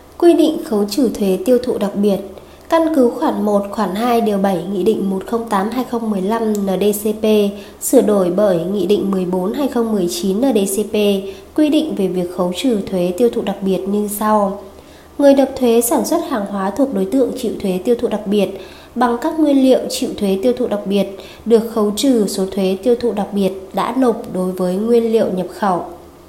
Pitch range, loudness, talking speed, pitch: 195-240 Hz, -16 LUFS, 190 wpm, 210 Hz